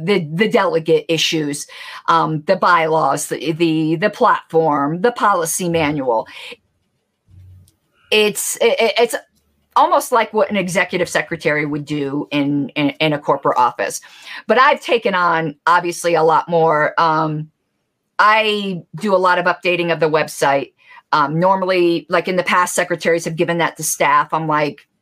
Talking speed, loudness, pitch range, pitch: 150 wpm, -16 LUFS, 155-185 Hz, 165 Hz